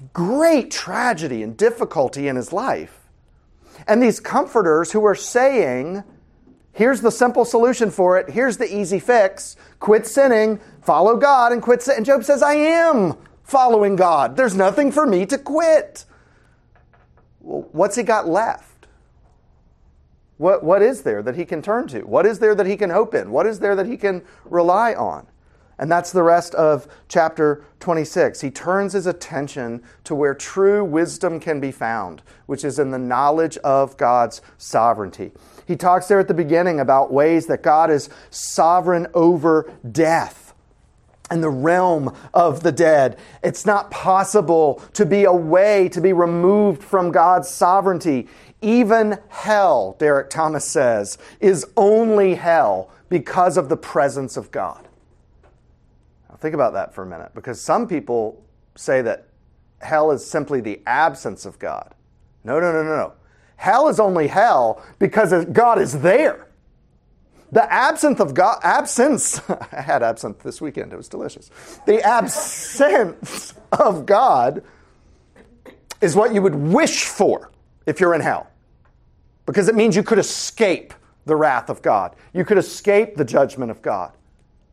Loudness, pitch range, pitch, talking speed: -18 LUFS, 150-215 Hz, 180 Hz, 155 wpm